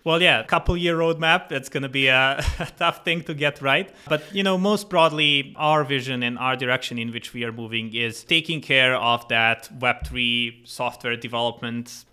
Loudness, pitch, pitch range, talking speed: -21 LUFS, 130 Hz, 120-165 Hz, 200 wpm